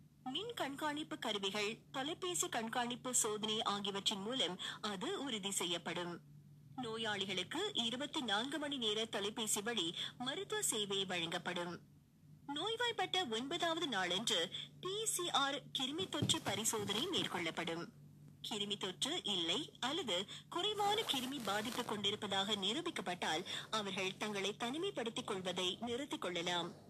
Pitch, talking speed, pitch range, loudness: 225 Hz, 100 wpm, 195-295 Hz, -39 LUFS